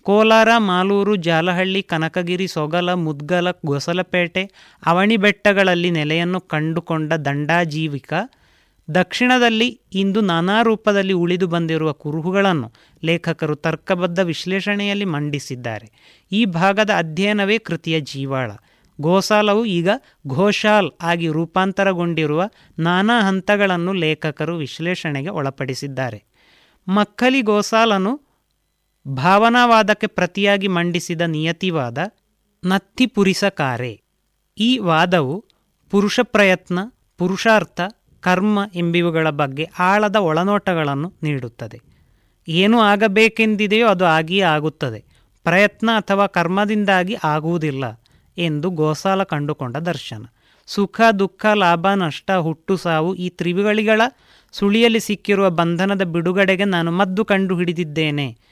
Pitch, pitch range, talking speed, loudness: 180 Hz, 160-200 Hz, 85 wpm, -18 LUFS